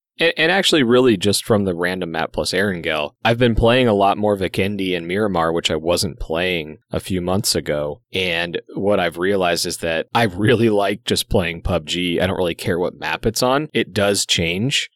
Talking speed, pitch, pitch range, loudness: 200 wpm, 95 Hz, 85-105 Hz, -19 LUFS